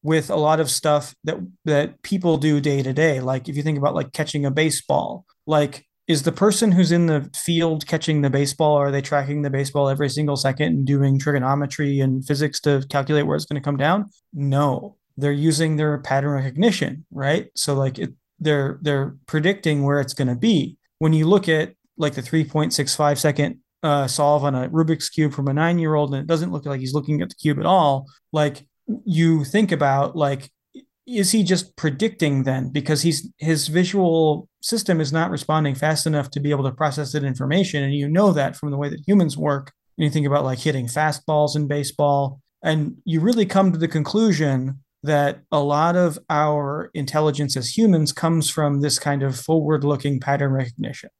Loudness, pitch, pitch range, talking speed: -21 LUFS, 150 Hz, 140-160 Hz, 200 wpm